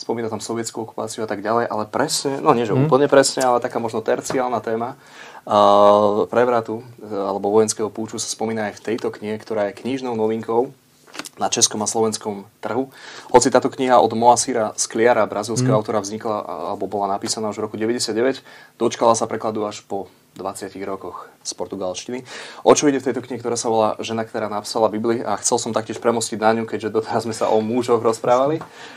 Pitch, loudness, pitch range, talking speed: 115 Hz, -20 LUFS, 105-120 Hz, 185 wpm